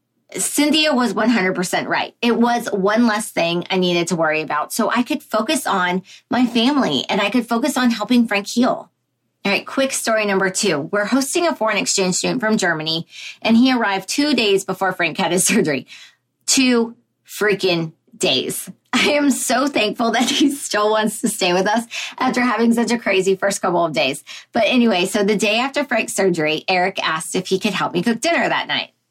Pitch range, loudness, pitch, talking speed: 190-250 Hz, -18 LUFS, 215 Hz, 200 wpm